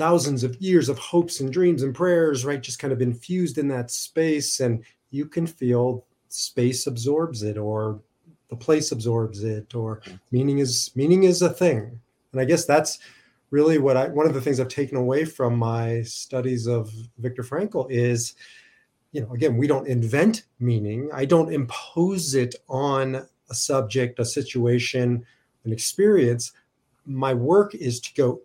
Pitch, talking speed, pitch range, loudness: 130 Hz, 170 wpm, 120-150 Hz, -23 LUFS